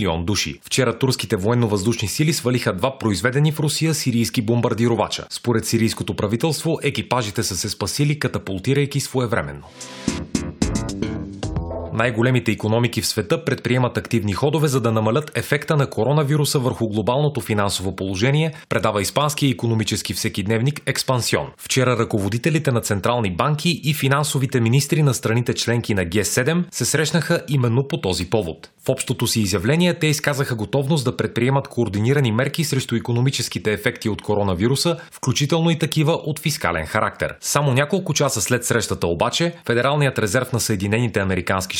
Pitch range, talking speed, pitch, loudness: 110-140 Hz, 140 wpm, 120 Hz, -20 LUFS